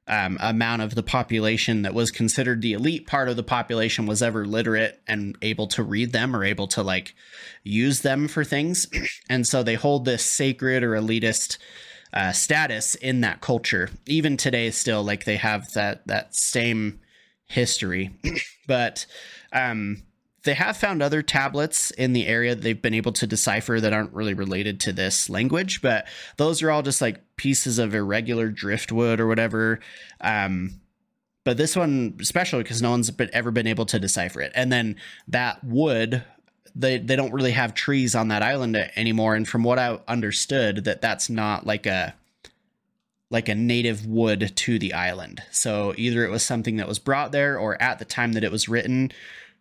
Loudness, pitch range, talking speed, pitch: -23 LUFS, 110-130 Hz, 185 wpm, 115 Hz